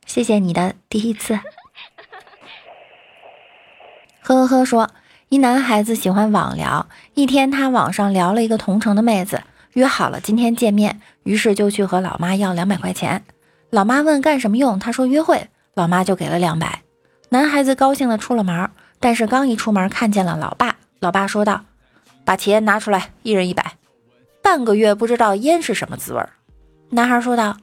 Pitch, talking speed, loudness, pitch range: 215 Hz, 265 characters per minute, -17 LUFS, 195-250 Hz